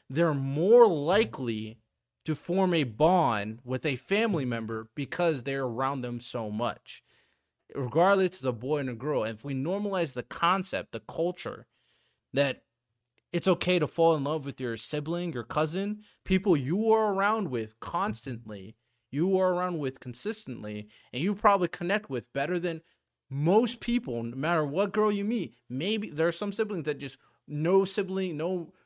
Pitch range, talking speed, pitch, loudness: 125-190 Hz, 165 wpm, 155 Hz, -29 LUFS